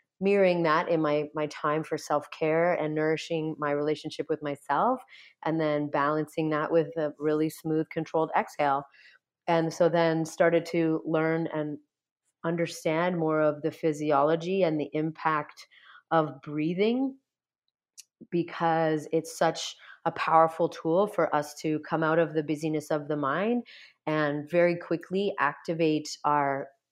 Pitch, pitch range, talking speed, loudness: 160 Hz, 150-170 Hz, 140 wpm, -28 LUFS